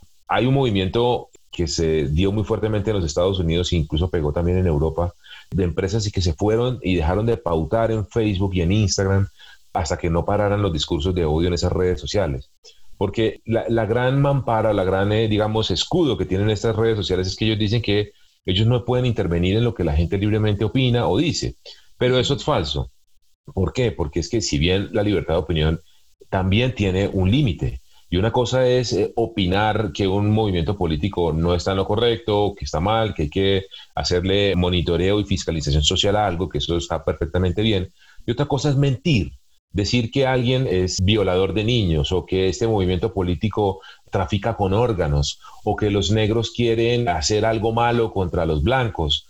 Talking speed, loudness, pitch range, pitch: 195 wpm, -21 LUFS, 90-110 Hz, 100 Hz